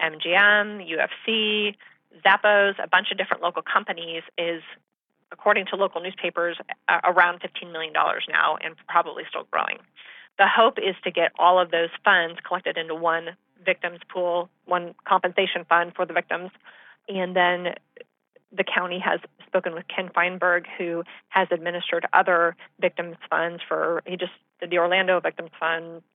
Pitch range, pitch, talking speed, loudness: 170-190 Hz, 180 Hz, 150 wpm, -23 LUFS